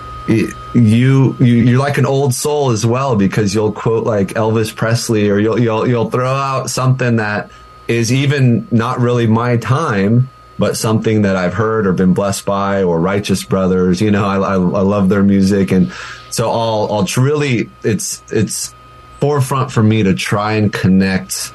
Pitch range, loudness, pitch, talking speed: 100-125 Hz, -14 LUFS, 115 Hz, 180 wpm